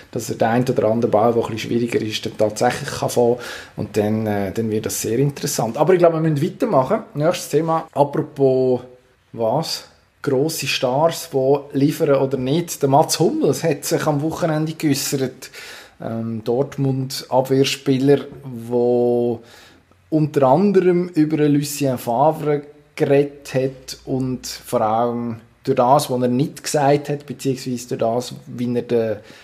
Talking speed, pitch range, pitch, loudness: 150 wpm, 120-150 Hz, 135 Hz, -19 LUFS